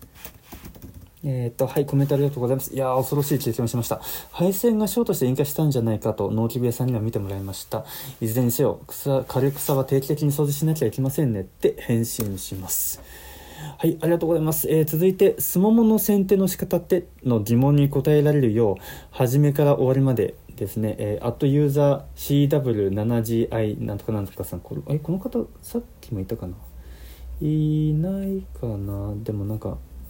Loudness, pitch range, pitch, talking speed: -23 LUFS, 110-150 Hz, 130 Hz, 400 characters per minute